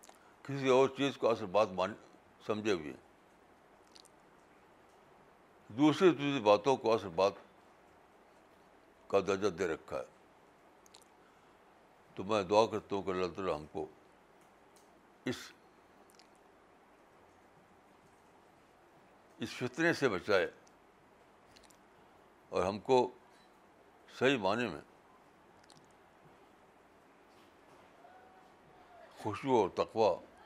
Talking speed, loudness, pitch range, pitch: 85 wpm, -33 LUFS, 100-135 Hz, 125 Hz